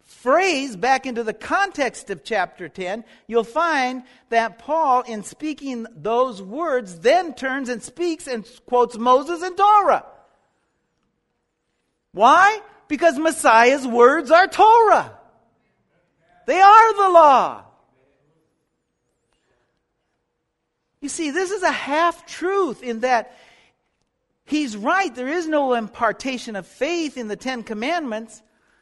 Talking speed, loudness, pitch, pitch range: 115 wpm, -18 LUFS, 260 Hz, 230-330 Hz